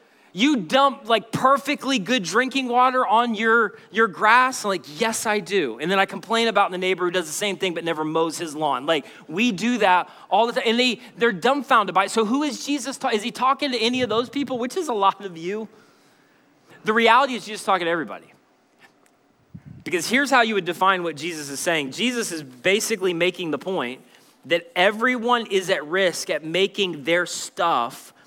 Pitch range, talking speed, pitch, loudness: 175-245 Hz, 210 wpm, 210 Hz, -21 LUFS